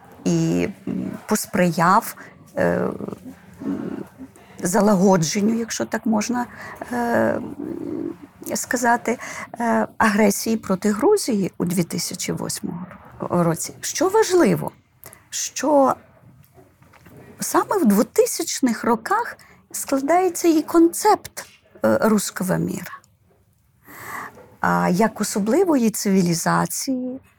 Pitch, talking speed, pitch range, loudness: 230 Hz, 65 wpm, 205-310 Hz, -21 LUFS